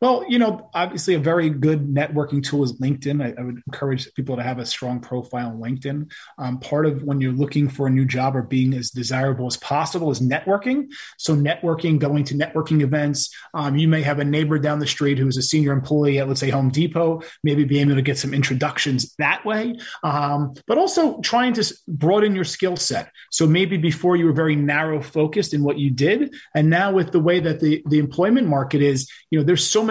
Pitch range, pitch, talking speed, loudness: 140-165 Hz, 150 Hz, 225 wpm, -20 LUFS